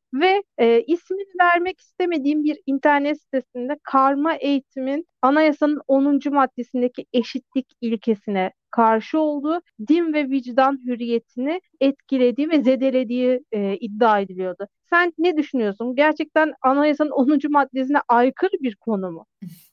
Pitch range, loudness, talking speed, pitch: 245-300 Hz, -20 LUFS, 115 wpm, 270 Hz